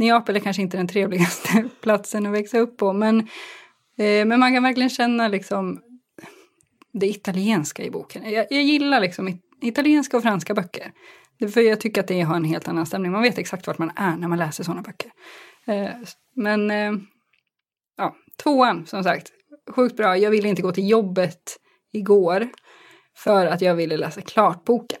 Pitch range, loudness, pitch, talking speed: 190-240 Hz, -21 LUFS, 210 Hz, 180 wpm